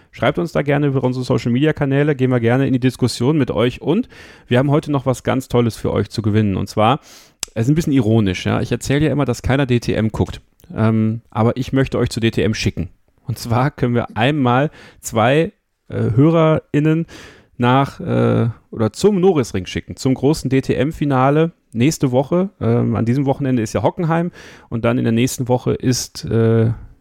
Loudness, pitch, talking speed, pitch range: -17 LUFS, 125 Hz, 190 wpm, 115-140 Hz